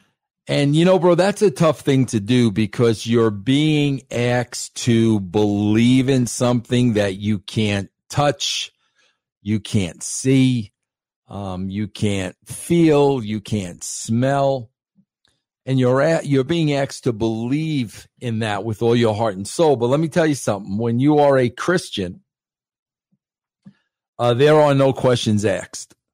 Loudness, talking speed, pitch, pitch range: -19 LUFS, 150 wpm, 120 Hz, 110-140 Hz